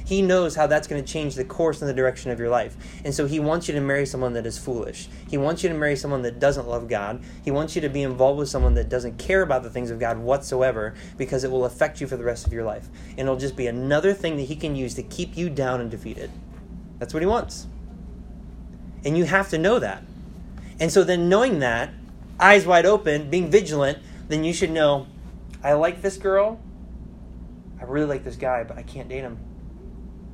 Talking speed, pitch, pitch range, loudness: 235 wpm, 140 Hz, 120-155 Hz, -23 LUFS